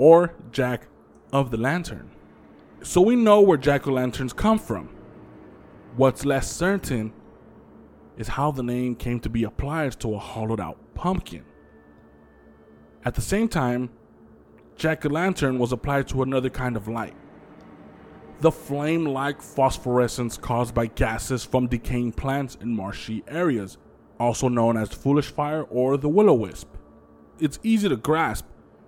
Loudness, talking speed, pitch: -24 LUFS, 150 wpm, 120 Hz